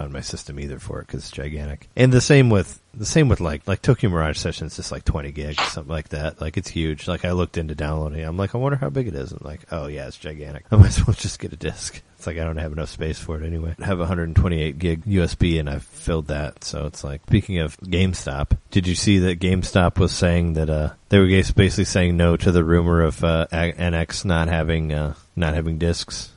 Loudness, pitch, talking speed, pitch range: -21 LUFS, 85 Hz, 250 wpm, 75-95 Hz